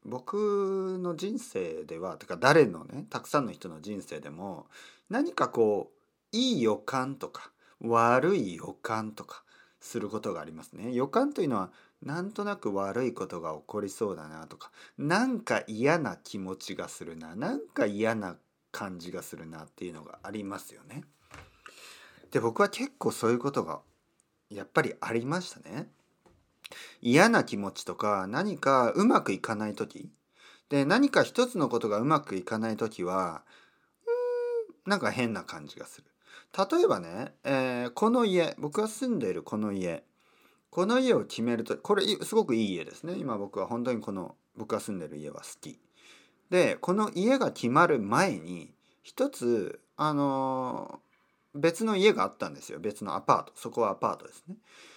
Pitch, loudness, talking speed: 145 Hz, -29 LUFS, 305 characters per minute